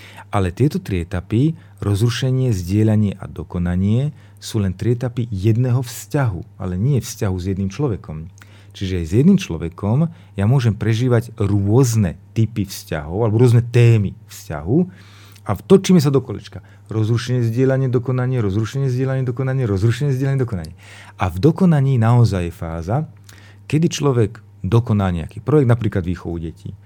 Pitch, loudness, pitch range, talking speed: 110 Hz, -19 LUFS, 100-125 Hz, 140 wpm